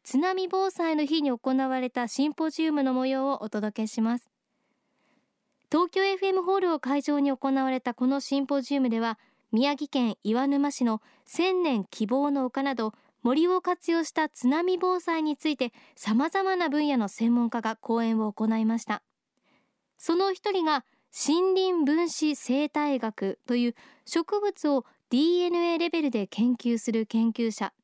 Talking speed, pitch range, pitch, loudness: 280 characters per minute, 235-320 Hz, 275 Hz, -27 LUFS